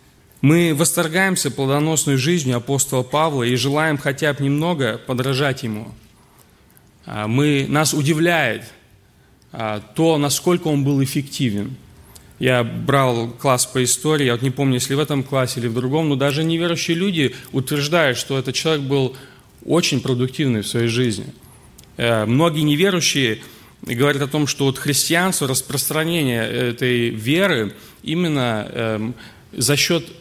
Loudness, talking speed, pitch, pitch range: -19 LUFS, 130 wpm, 135 Hz, 125-155 Hz